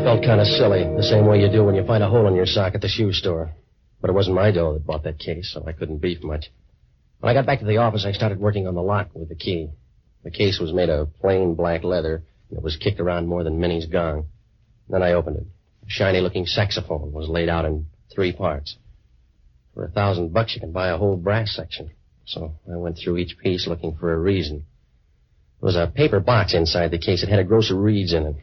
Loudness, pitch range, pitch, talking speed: -21 LUFS, 80-105 Hz, 90 Hz, 250 wpm